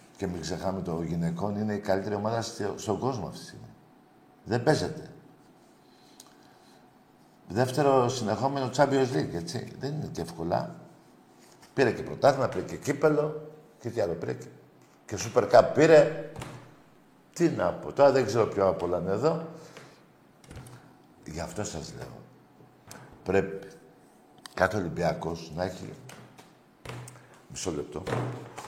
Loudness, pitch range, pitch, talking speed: -28 LUFS, 90-140 Hz, 110 Hz, 130 wpm